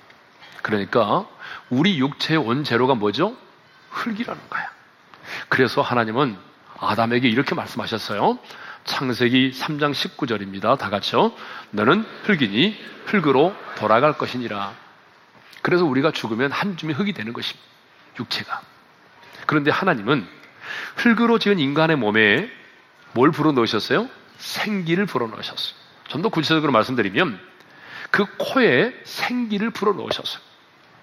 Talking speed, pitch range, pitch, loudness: 290 characters per minute, 120-200 Hz, 150 Hz, -21 LUFS